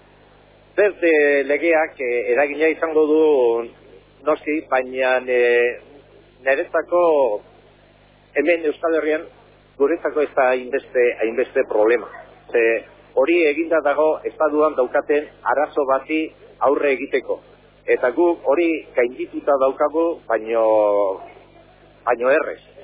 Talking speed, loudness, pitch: 85 wpm, -19 LUFS, 155 Hz